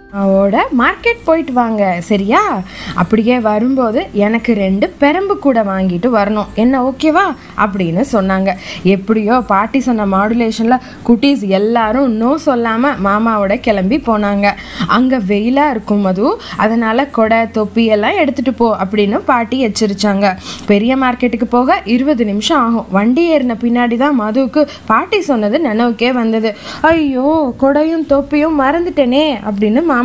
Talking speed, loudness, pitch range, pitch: 125 wpm, -13 LUFS, 210-275 Hz, 235 Hz